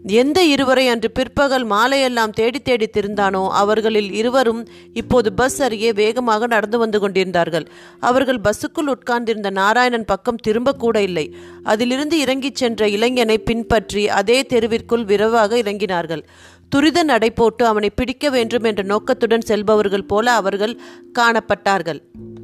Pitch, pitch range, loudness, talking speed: 230 Hz, 205-250 Hz, -17 LUFS, 120 wpm